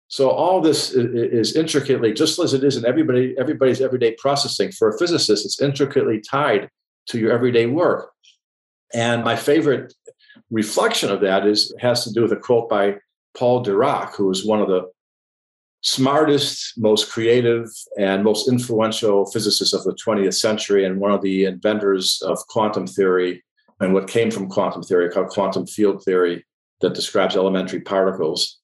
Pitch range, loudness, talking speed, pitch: 100-130 Hz, -19 LUFS, 165 wpm, 115 Hz